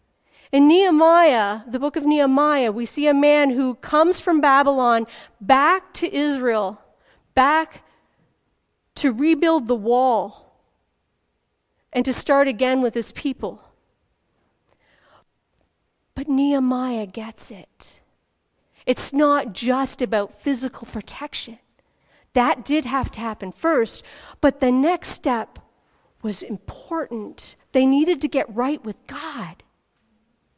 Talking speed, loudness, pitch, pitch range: 115 wpm, -20 LUFS, 270 Hz, 235-295 Hz